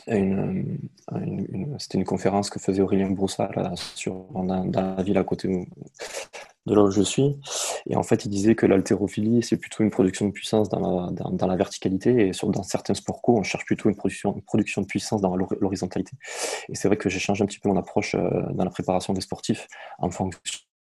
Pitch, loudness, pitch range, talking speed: 100 Hz, -25 LUFS, 95-105 Hz, 225 wpm